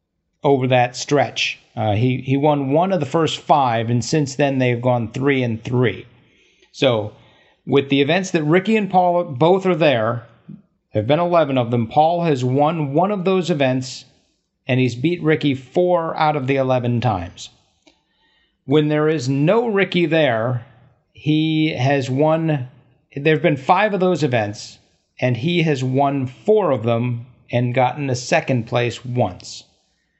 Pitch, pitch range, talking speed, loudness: 140 Hz, 125-160 Hz, 165 wpm, -18 LUFS